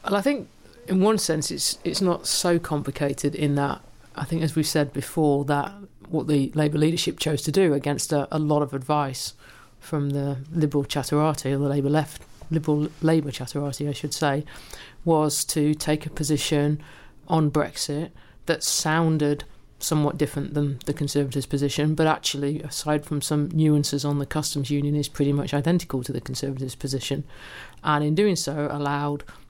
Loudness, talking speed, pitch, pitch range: -24 LUFS, 175 wpm, 150 Hz, 140-155 Hz